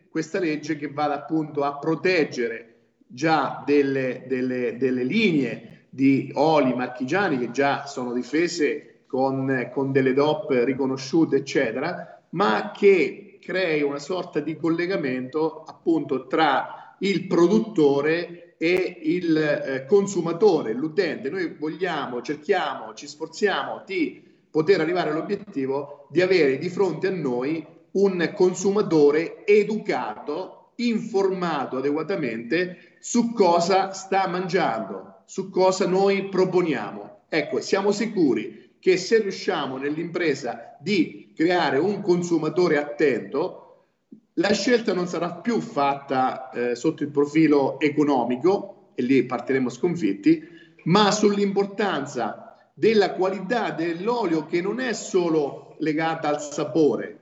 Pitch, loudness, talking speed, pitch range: 165 Hz, -23 LUFS, 115 wpm, 140-195 Hz